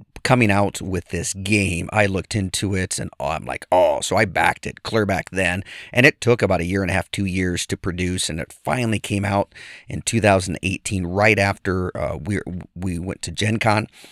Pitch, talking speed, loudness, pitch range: 95 Hz, 210 wpm, -21 LUFS, 90-105 Hz